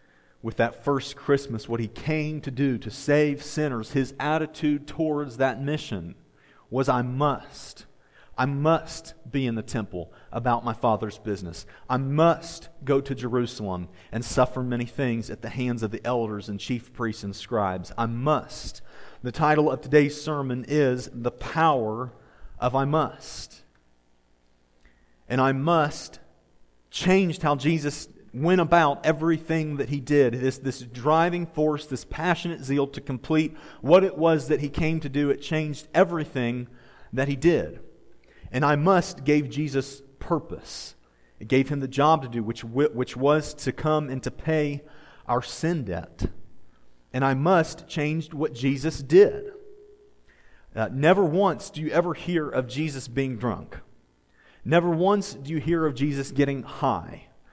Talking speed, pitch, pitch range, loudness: 155 wpm, 140 Hz, 120-155 Hz, -25 LUFS